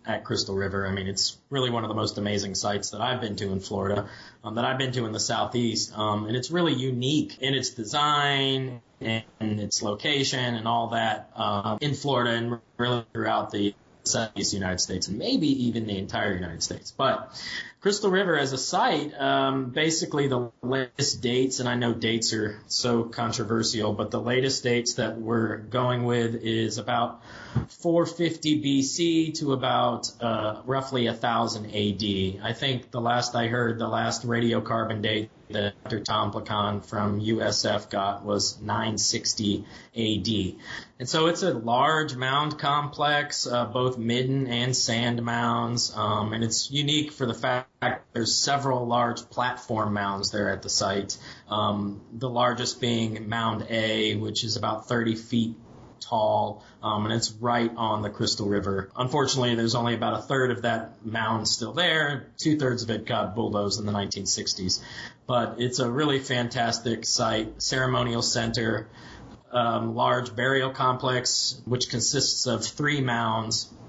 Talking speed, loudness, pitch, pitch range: 160 wpm, -26 LUFS, 115 Hz, 110-130 Hz